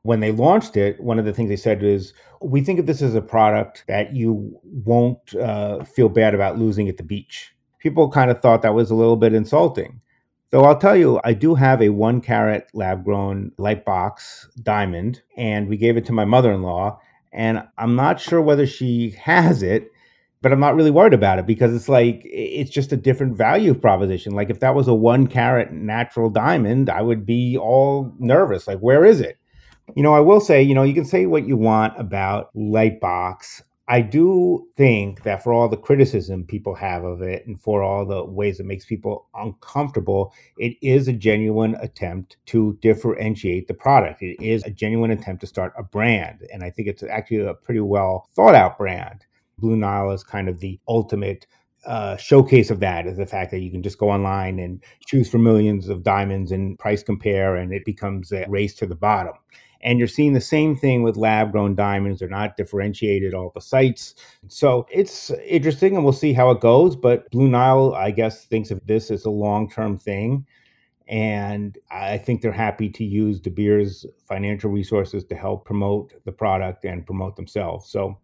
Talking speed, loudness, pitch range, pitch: 205 wpm, -19 LUFS, 100-125 Hz, 110 Hz